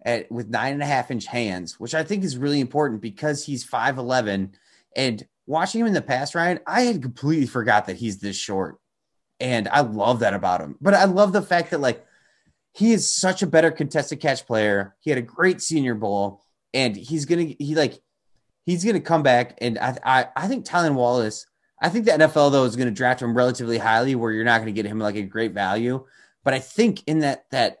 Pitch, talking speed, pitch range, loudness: 130 Hz, 220 wpm, 115-160 Hz, -22 LUFS